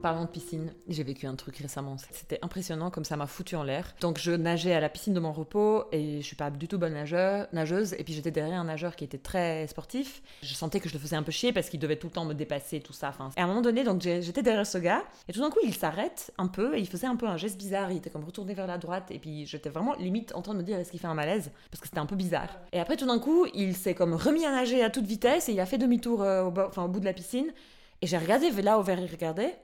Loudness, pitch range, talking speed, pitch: -30 LUFS, 160-205 Hz, 310 wpm, 175 Hz